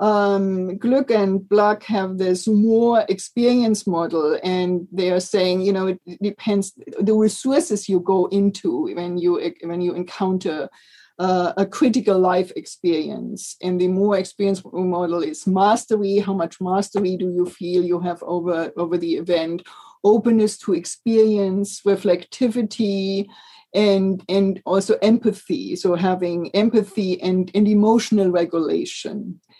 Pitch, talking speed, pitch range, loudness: 195 Hz, 135 wpm, 180-210 Hz, -20 LUFS